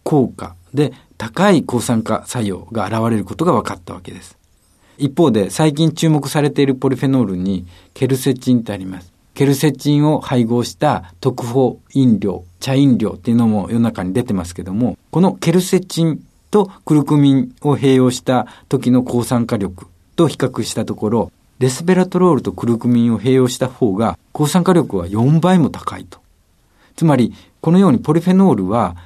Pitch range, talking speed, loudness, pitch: 105-145 Hz, 355 characters per minute, -16 LUFS, 125 Hz